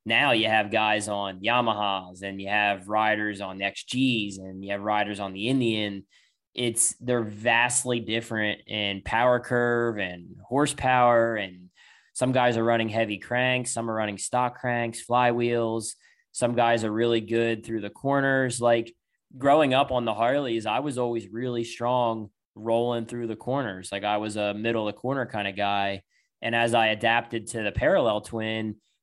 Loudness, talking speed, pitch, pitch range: -25 LUFS, 175 wpm, 115 Hz, 105-120 Hz